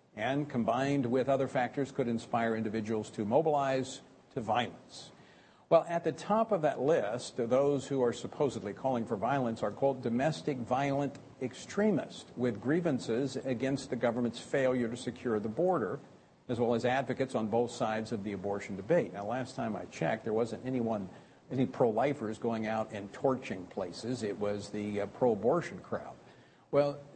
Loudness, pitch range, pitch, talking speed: -33 LUFS, 110-140 Hz, 125 Hz, 175 wpm